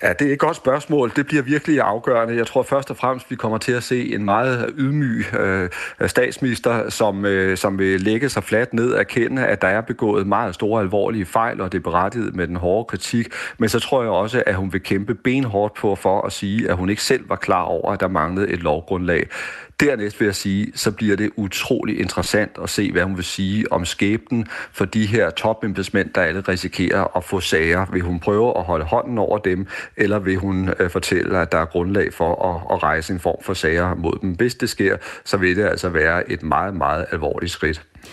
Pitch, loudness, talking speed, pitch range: 105 Hz, -20 LUFS, 225 wpm, 95-120 Hz